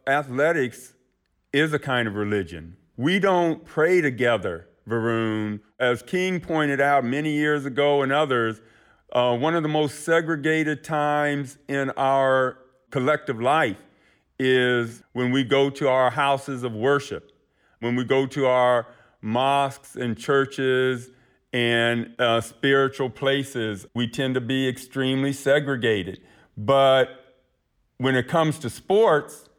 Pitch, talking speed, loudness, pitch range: 130 Hz, 130 wpm, -23 LUFS, 120-145 Hz